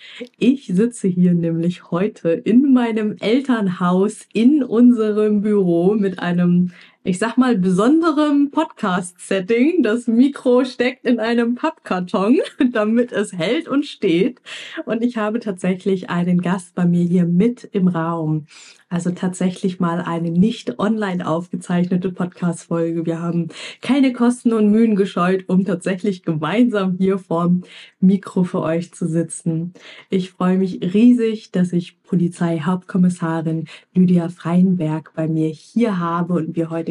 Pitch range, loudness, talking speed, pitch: 175-225 Hz, -18 LUFS, 135 wpm, 190 Hz